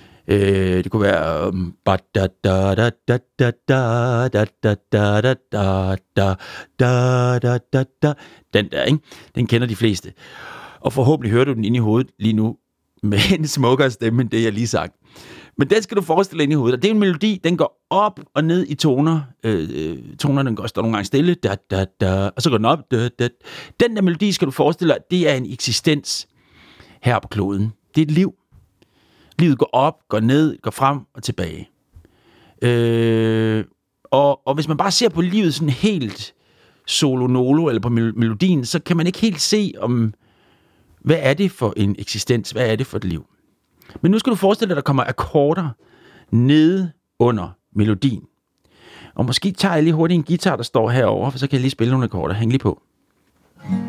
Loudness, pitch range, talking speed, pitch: -19 LUFS, 110-155 Hz, 175 wpm, 125 Hz